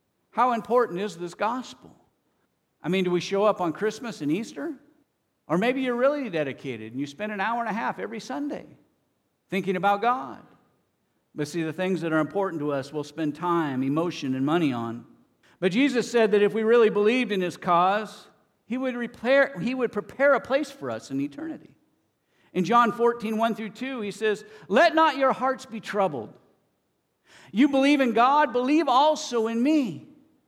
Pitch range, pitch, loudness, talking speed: 180-250 Hz, 215 Hz, -25 LUFS, 185 wpm